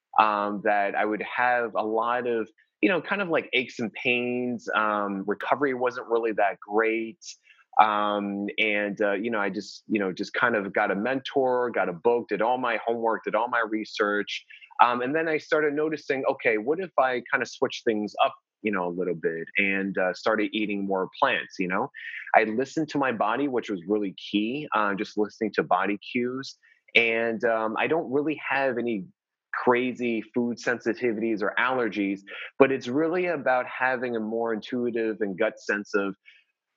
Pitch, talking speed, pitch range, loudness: 115 Hz, 190 wpm, 105-125 Hz, -26 LUFS